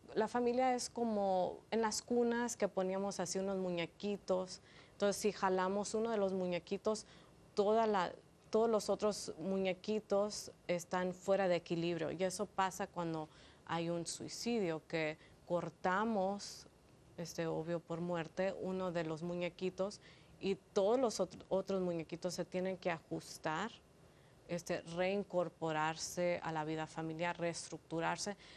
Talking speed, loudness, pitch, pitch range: 130 wpm, -39 LUFS, 185 Hz, 170-200 Hz